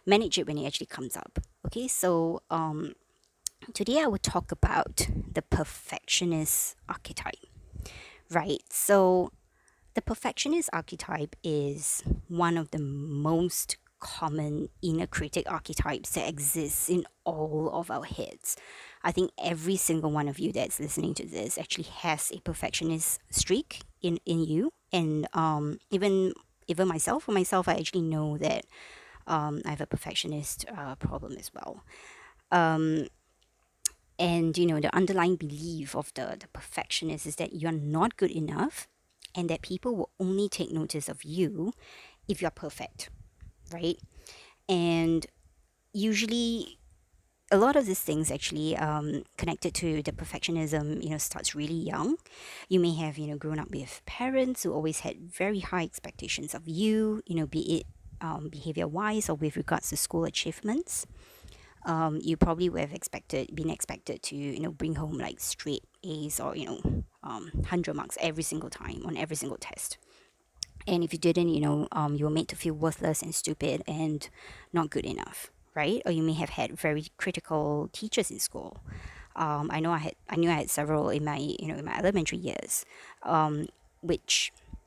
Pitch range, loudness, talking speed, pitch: 155-180 Hz, -30 LUFS, 165 wpm, 165 Hz